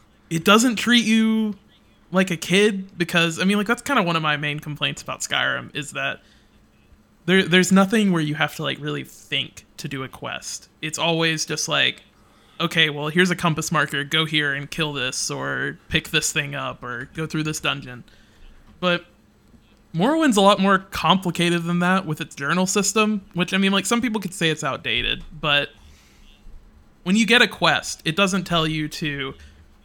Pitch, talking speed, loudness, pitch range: 165 Hz, 190 wpm, -21 LUFS, 145-190 Hz